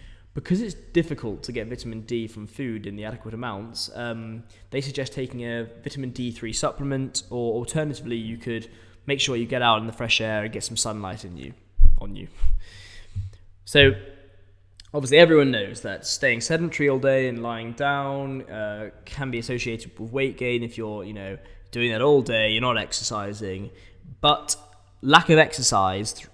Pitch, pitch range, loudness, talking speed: 115 Hz, 100-135 Hz, -24 LUFS, 180 wpm